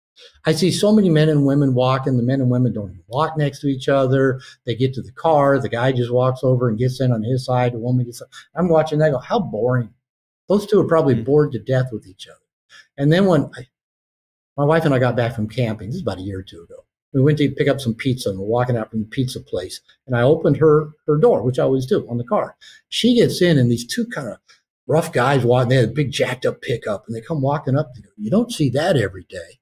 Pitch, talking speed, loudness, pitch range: 130 Hz, 270 wpm, -19 LUFS, 120-155 Hz